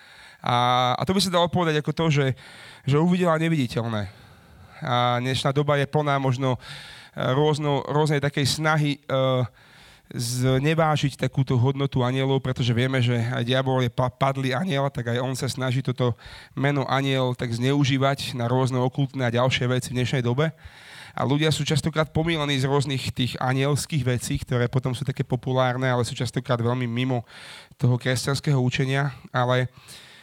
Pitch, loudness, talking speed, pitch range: 130 Hz, -24 LUFS, 155 wpm, 125-145 Hz